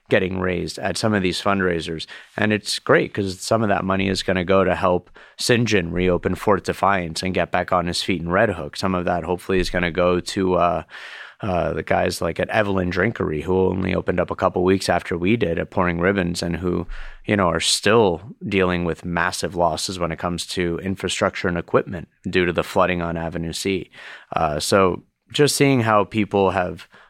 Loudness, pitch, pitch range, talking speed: -21 LUFS, 90 Hz, 85-95 Hz, 210 wpm